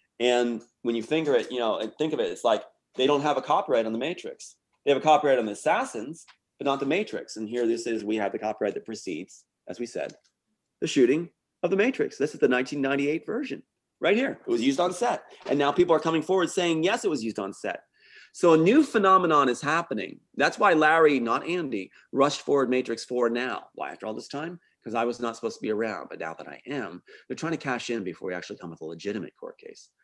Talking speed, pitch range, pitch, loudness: 245 wpm, 115-175 Hz, 140 Hz, -26 LUFS